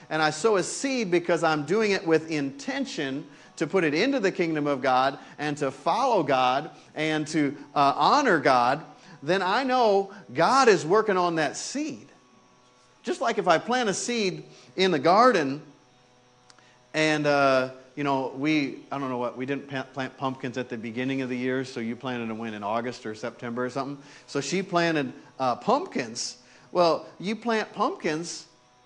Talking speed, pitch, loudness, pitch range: 180 wpm, 145 Hz, -25 LUFS, 130-175 Hz